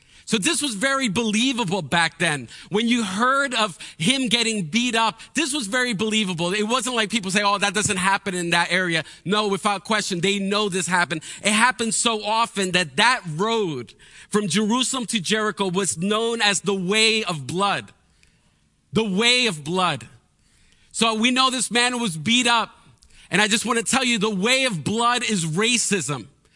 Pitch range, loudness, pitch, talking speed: 185-235 Hz, -21 LUFS, 210 Hz, 185 wpm